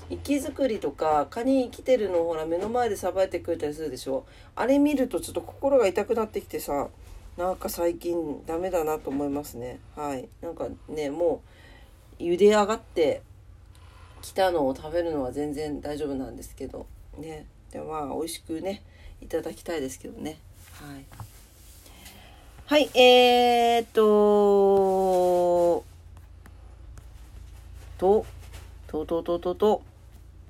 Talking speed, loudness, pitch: 270 characters per minute, -25 LUFS, 150 Hz